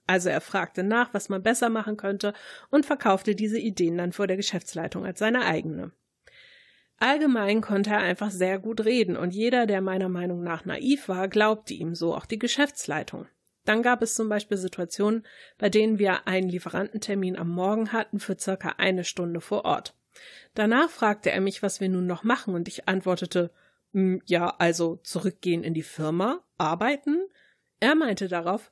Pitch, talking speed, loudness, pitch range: 200 Hz, 175 wpm, -26 LUFS, 185-225 Hz